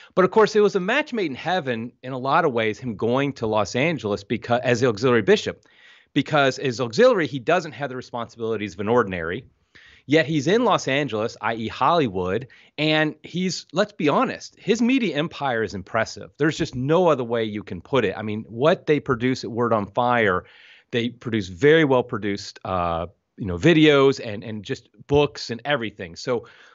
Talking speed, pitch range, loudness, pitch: 195 wpm, 115-155 Hz, -22 LUFS, 130 Hz